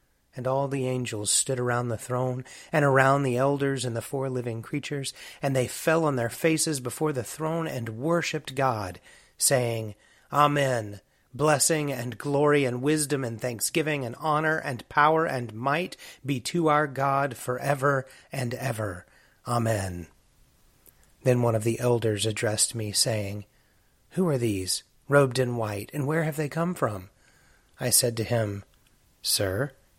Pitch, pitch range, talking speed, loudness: 130 Hz, 115-145 Hz, 155 wpm, -26 LUFS